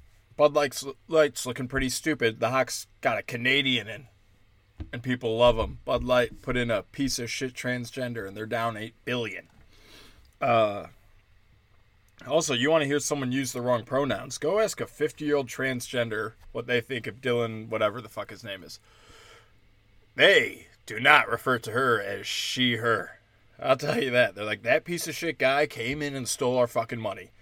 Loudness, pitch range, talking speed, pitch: -26 LUFS, 110-135 Hz, 180 wpm, 125 Hz